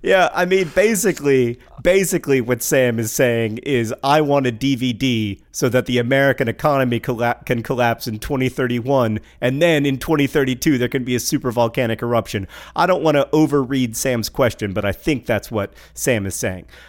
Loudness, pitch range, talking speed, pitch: -18 LUFS, 120-140 Hz, 175 wpm, 130 Hz